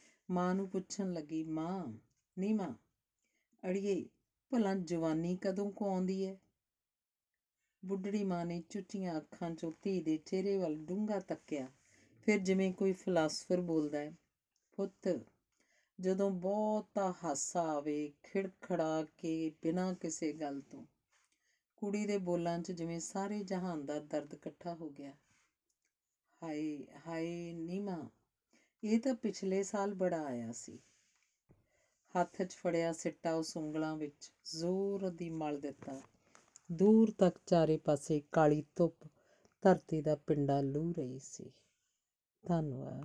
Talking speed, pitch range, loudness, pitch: 125 wpm, 155-195 Hz, -37 LUFS, 170 Hz